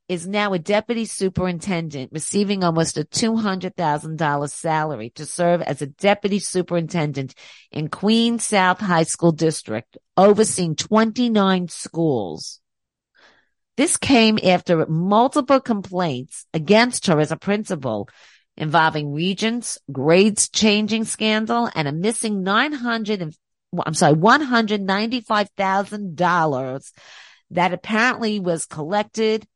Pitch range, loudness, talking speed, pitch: 160-215 Hz, -20 LUFS, 125 wpm, 185 Hz